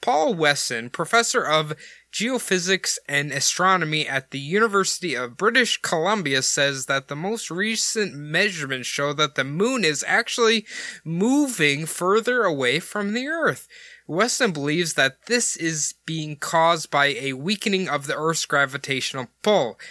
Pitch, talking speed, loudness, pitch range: 165 Hz, 140 wpm, -22 LUFS, 140-215 Hz